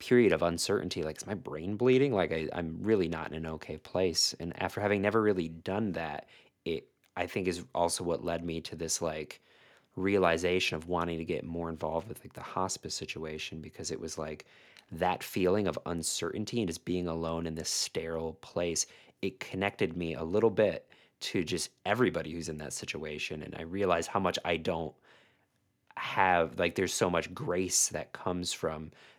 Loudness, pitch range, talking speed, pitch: -32 LUFS, 80-95 Hz, 190 wpm, 85 Hz